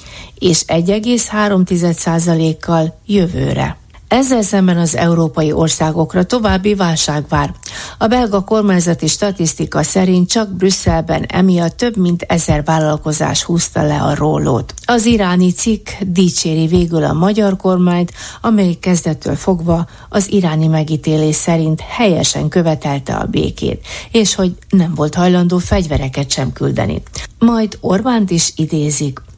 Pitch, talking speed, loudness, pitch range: 170 Hz, 120 wpm, -14 LUFS, 160-195 Hz